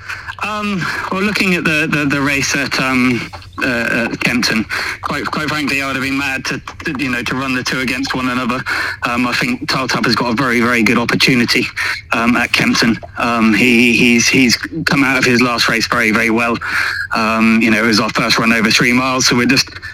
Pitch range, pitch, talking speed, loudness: 115-140 Hz, 130 Hz, 215 wpm, -14 LUFS